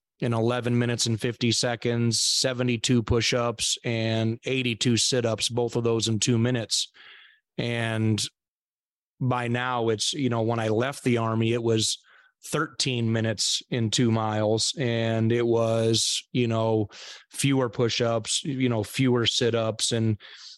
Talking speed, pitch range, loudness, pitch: 135 wpm, 110-125 Hz, -25 LUFS, 115 Hz